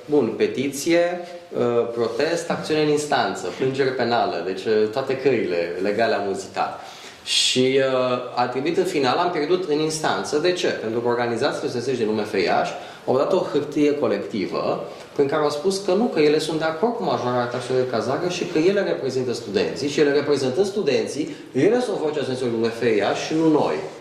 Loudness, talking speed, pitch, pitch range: -22 LUFS, 175 wpm, 145 Hz, 125-170 Hz